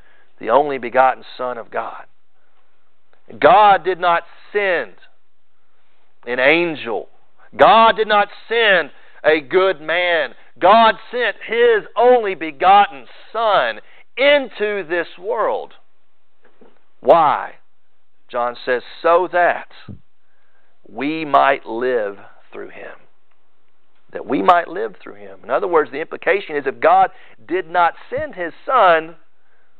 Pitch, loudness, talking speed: 195 Hz, -16 LUFS, 115 wpm